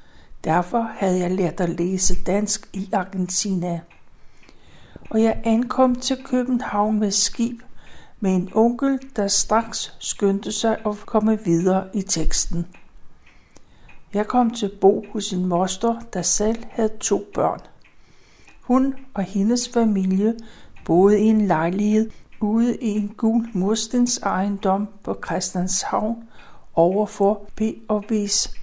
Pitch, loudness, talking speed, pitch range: 210 Hz, -21 LUFS, 125 wpm, 190-225 Hz